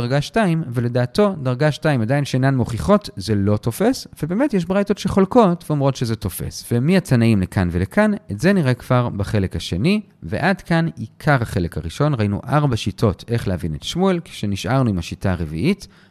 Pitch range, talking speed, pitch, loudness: 105-175 Hz, 160 wpm, 130 Hz, -19 LUFS